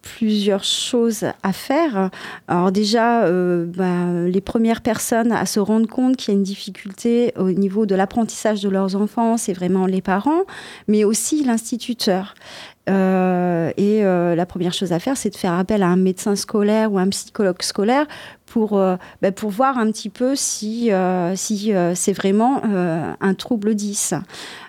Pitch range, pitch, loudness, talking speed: 185-225 Hz, 205 Hz, -19 LUFS, 175 wpm